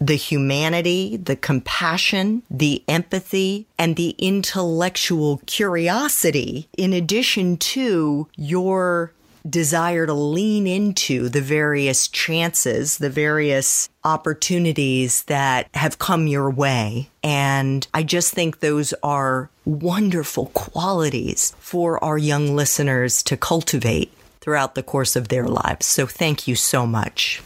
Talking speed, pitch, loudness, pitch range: 120 wpm, 155 Hz, -20 LUFS, 140-175 Hz